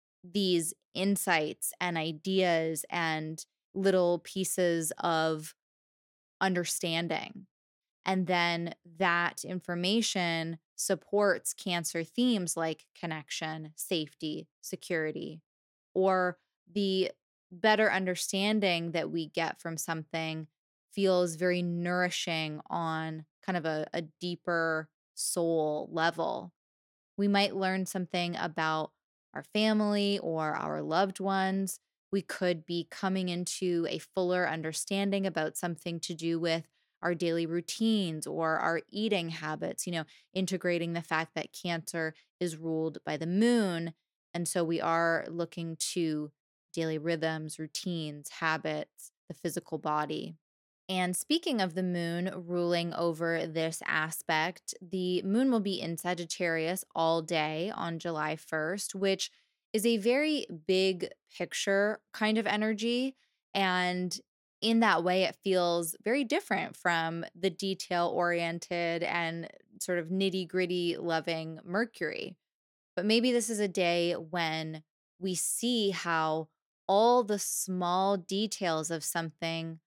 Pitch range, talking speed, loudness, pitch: 165-190 Hz, 120 wpm, -31 LUFS, 175 Hz